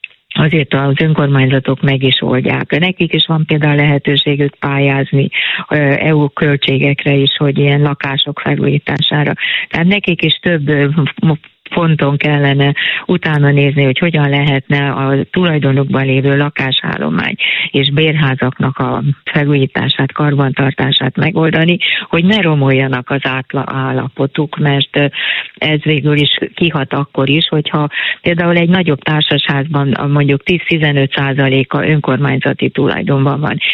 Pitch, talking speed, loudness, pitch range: 145 Hz, 110 wpm, -12 LUFS, 135-155 Hz